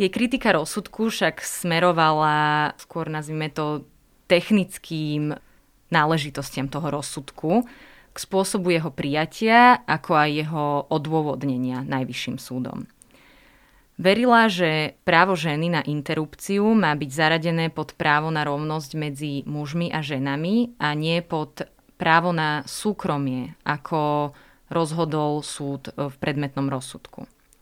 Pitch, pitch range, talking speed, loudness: 155 Hz, 145-175 Hz, 110 wpm, -23 LUFS